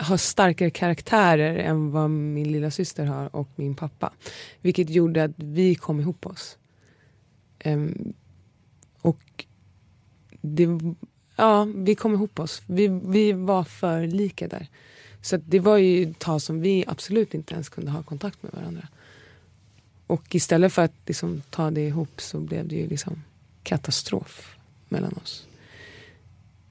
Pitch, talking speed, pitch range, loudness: 155 Hz, 150 wpm, 140-180 Hz, -24 LUFS